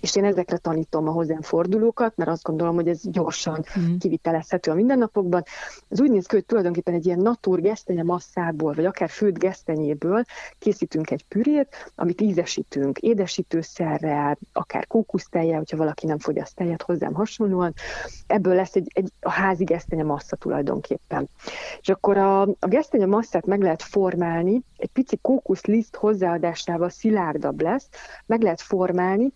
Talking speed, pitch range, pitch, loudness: 150 wpm, 170-210 Hz, 185 Hz, -23 LUFS